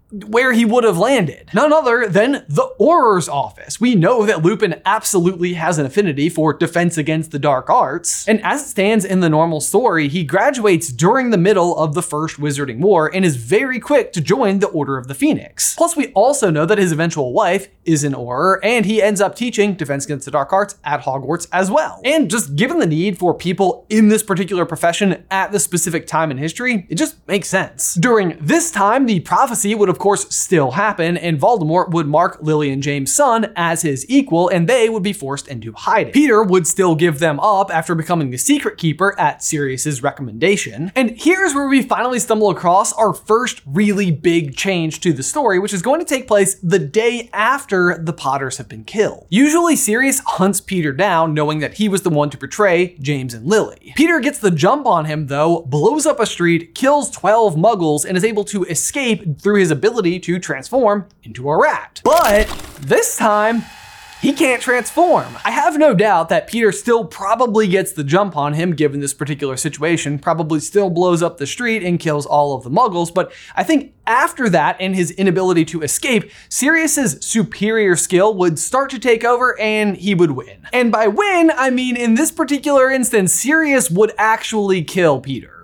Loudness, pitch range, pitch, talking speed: -16 LUFS, 160-225 Hz, 190 Hz, 200 wpm